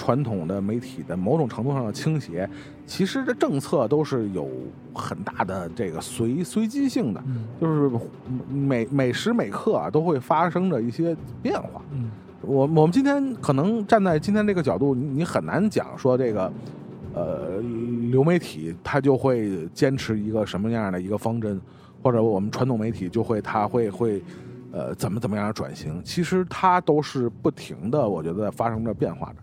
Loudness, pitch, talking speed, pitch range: -24 LUFS, 130 Hz, 265 characters per minute, 115-160 Hz